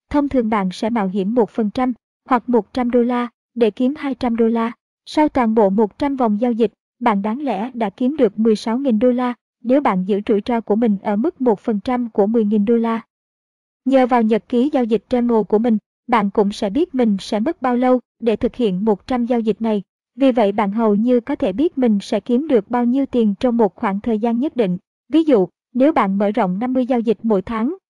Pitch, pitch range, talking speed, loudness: 235 Hz, 215-250 Hz, 225 wpm, -18 LUFS